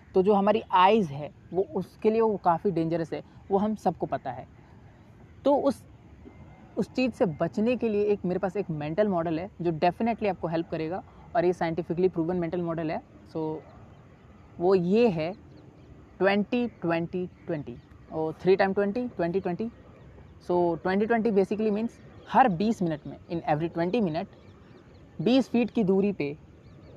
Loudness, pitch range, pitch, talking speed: -27 LUFS, 170-210 Hz, 185 Hz, 170 wpm